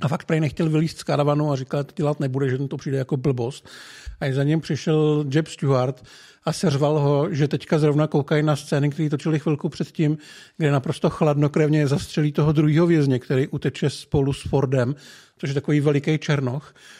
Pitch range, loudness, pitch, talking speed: 140-155 Hz, -22 LUFS, 150 Hz, 195 wpm